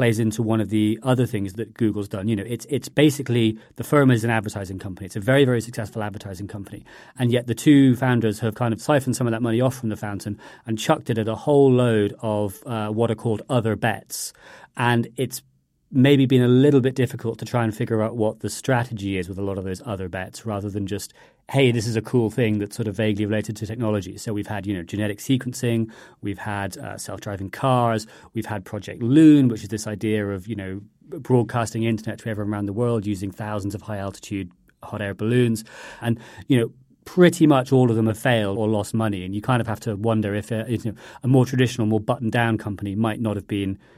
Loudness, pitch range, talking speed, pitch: -22 LUFS, 105-120 Hz, 235 wpm, 110 Hz